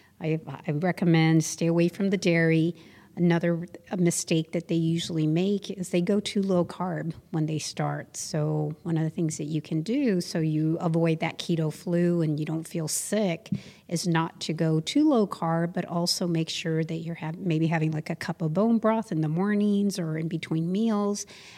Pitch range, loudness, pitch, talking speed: 160-180 Hz, -27 LUFS, 165 Hz, 195 wpm